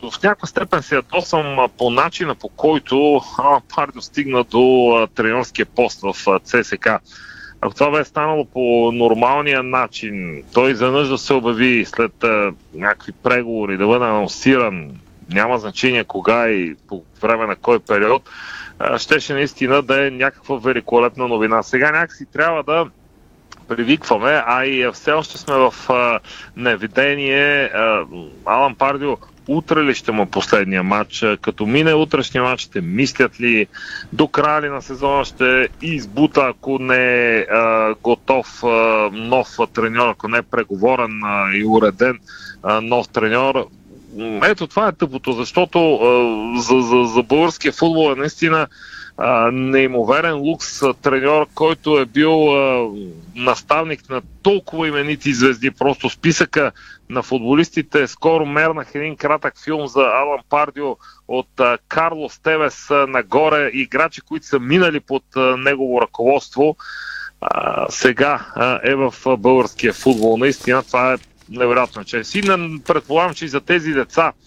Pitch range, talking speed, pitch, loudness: 120-150 Hz, 145 wpm, 135 Hz, -17 LUFS